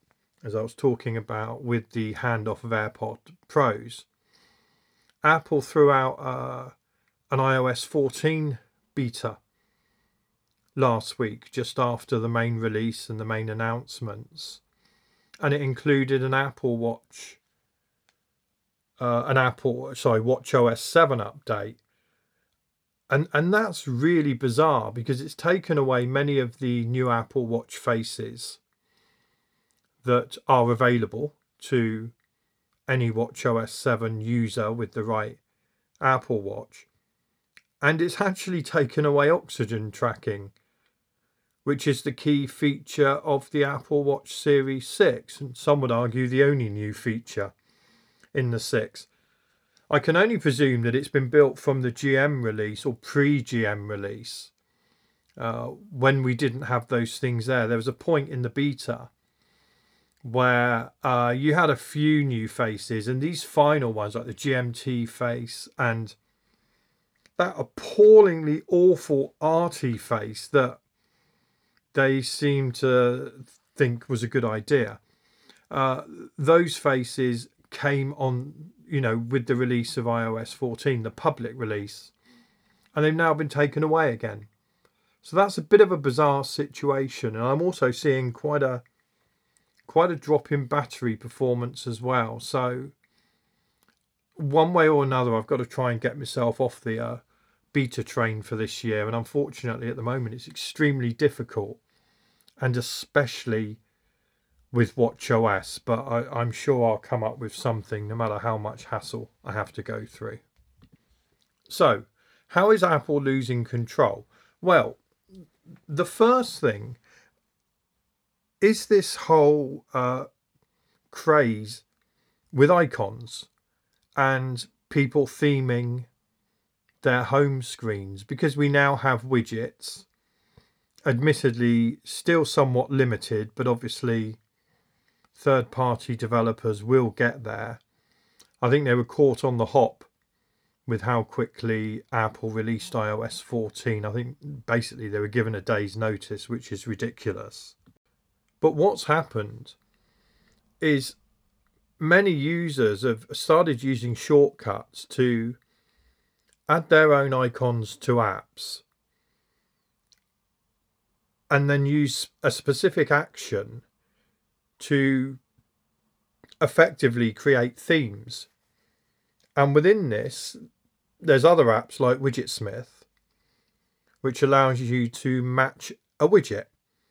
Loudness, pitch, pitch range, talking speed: -24 LUFS, 125 Hz, 115-145 Hz, 125 wpm